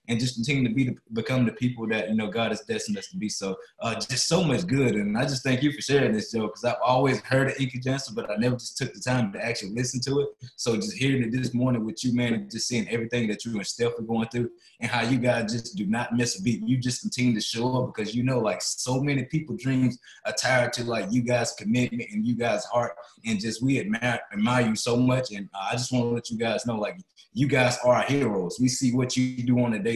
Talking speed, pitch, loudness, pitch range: 275 wpm, 125 Hz, -26 LUFS, 115-130 Hz